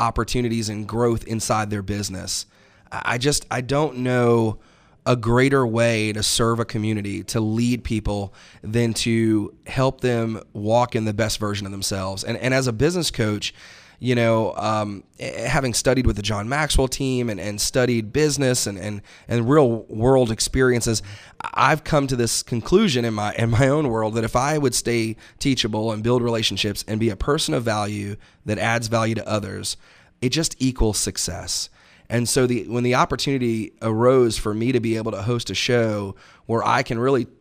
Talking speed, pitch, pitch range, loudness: 180 wpm, 115 Hz, 105-125 Hz, -21 LUFS